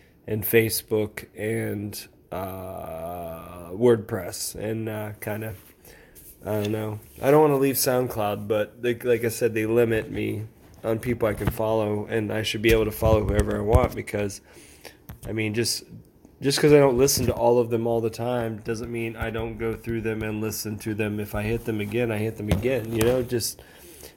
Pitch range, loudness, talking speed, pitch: 105-115 Hz, -25 LUFS, 200 wpm, 110 Hz